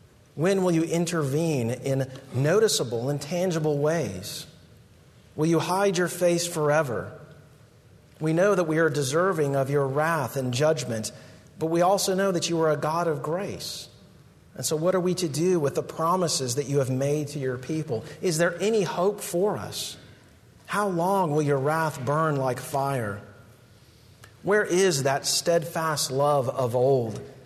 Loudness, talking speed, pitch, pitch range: -25 LUFS, 165 wpm, 155 Hz, 135-170 Hz